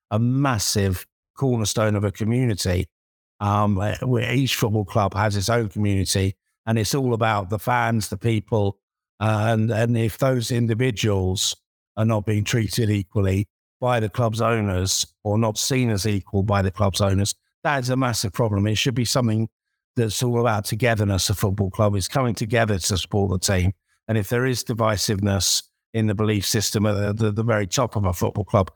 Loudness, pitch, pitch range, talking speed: -22 LUFS, 110 Hz, 100-115 Hz, 185 wpm